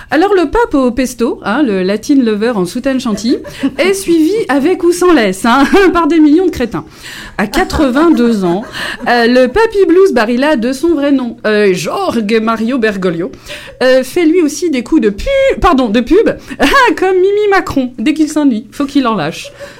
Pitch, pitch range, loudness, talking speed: 275 Hz, 230-340 Hz, -11 LUFS, 190 wpm